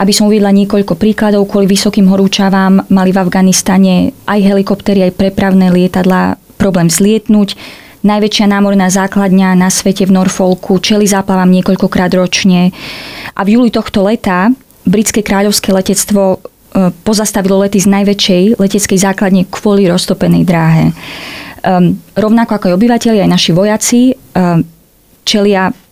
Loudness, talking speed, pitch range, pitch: -9 LUFS, 125 wpm, 185-205 Hz, 195 Hz